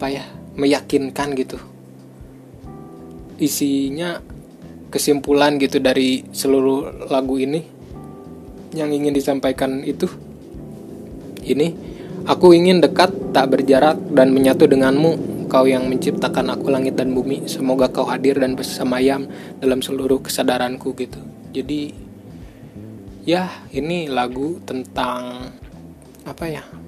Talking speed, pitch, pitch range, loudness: 105 wpm, 135 Hz, 125-145 Hz, -18 LUFS